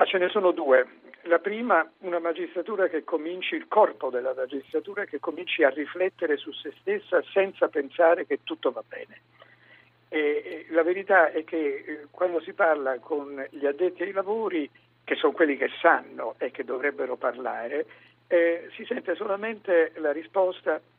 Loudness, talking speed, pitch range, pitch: -26 LUFS, 165 wpm, 160-240 Hz, 180 Hz